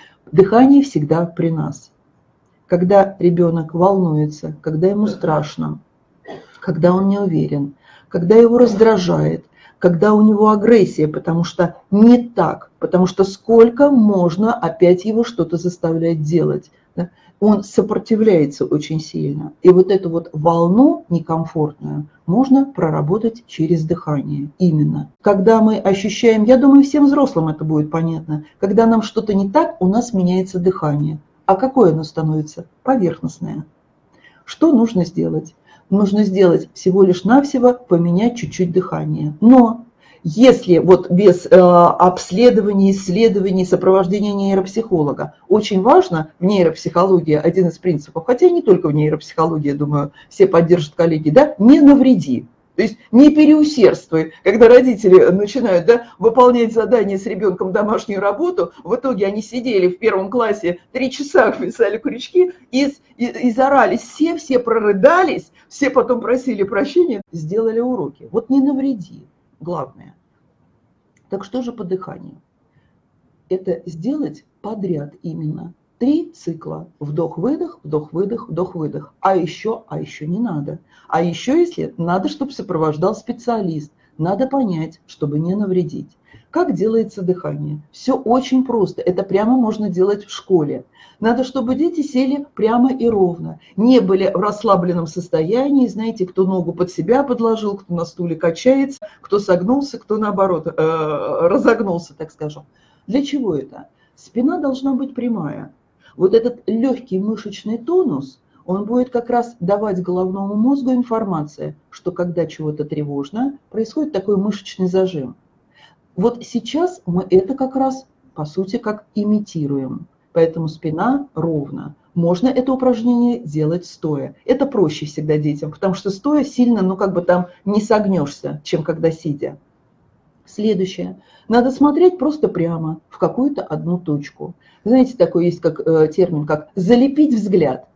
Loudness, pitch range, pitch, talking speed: -16 LUFS, 170-240 Hz, 195 Hz, 135 wpm